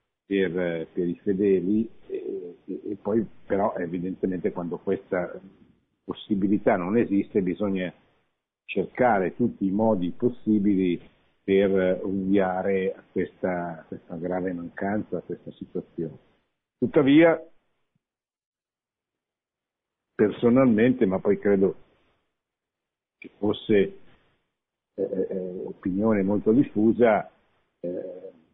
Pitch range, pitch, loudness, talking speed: 90-110 Hz, 100 Hz, -25 LUFS, 90 wpm